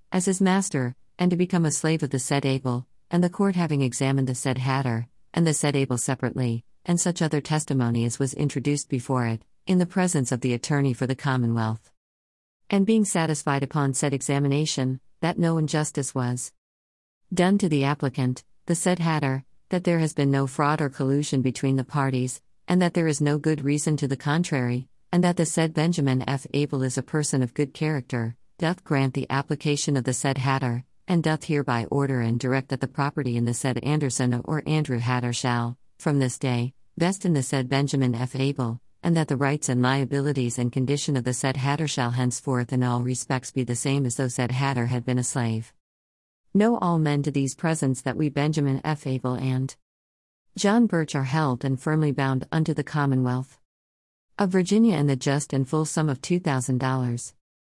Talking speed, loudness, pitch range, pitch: 200 wpm, -25 LUFS, 125-155 Hz, 135 Hz